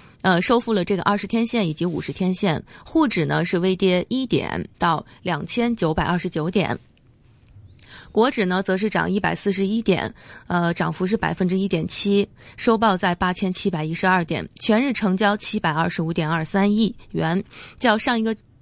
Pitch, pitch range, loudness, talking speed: 190 Hz, 170-210 Hz, -21 LUFS, 270 characters per minute